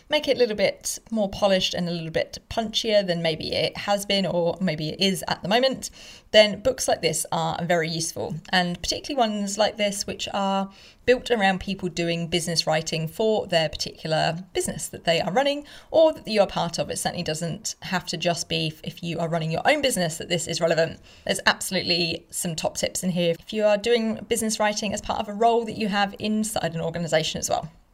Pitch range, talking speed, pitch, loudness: 170-215 Hz, 220 wpm, 185 Hz, -24 LUFS